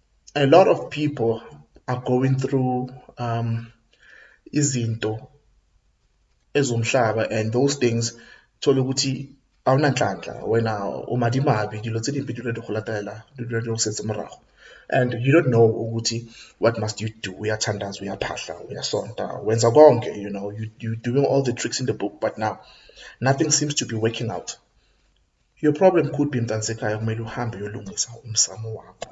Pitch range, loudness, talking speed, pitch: 110-130 Hz, -23 LUFS, 145 wpm, 115 Hz